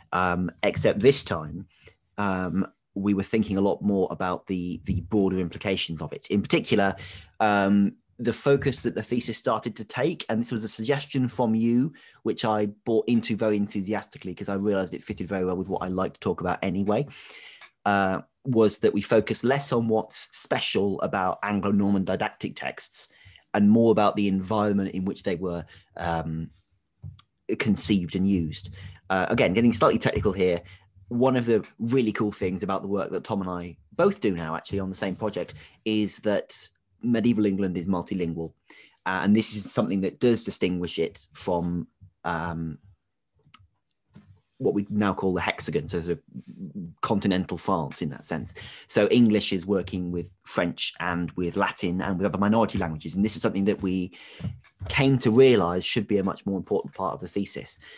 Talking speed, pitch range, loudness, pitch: 180 wpm, 95-110 Hz, -26 LUFS, 100 Hz